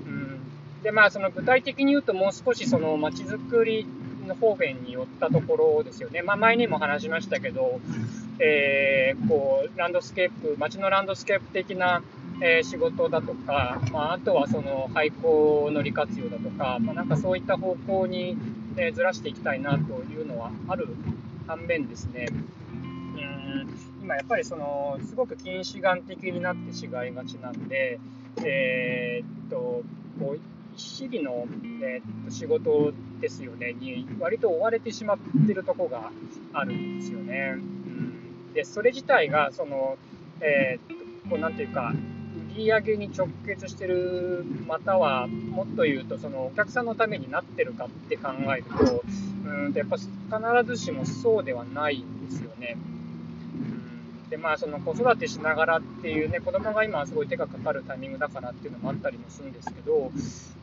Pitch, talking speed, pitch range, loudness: 195 Hz, 325 characters per minute, 140-240 Hz, -27 LUFS